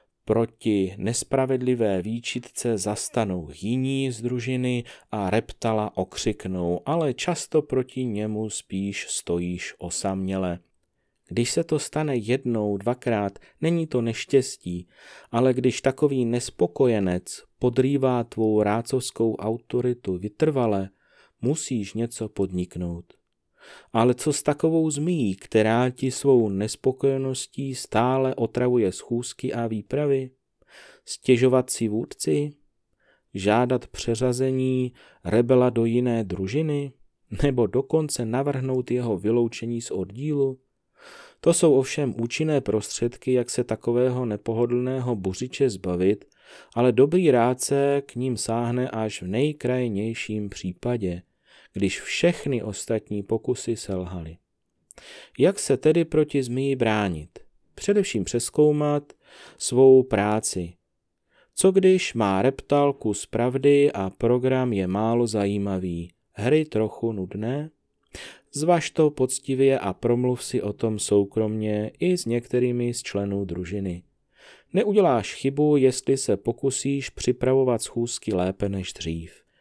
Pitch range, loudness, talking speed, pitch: 105-135 Hz, -24 LUFS, 110 wpm, 120 Hz